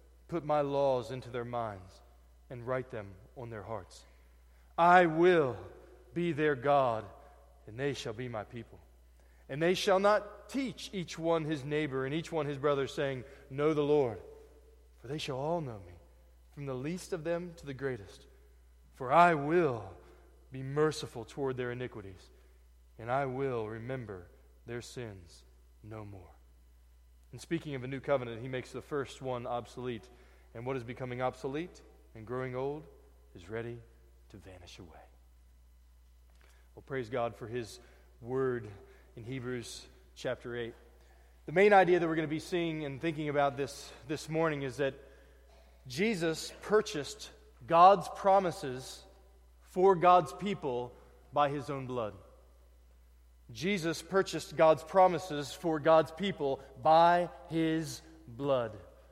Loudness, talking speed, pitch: -32 LUFS, 145 wpm, 130 Hz